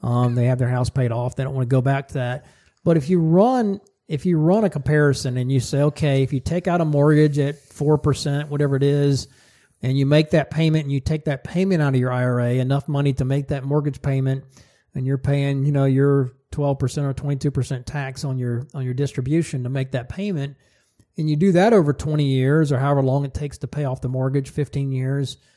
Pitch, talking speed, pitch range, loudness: 140 Hz, 245 wpm, 130-150 Hz, -21 LUFS